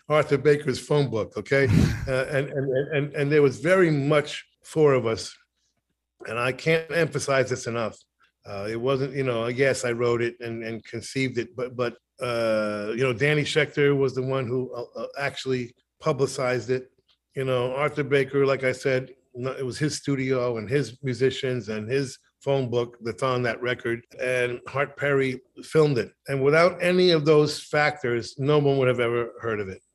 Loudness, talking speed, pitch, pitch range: -25 LUFS, 185 wpm, 130 Hz, 120-145 Hz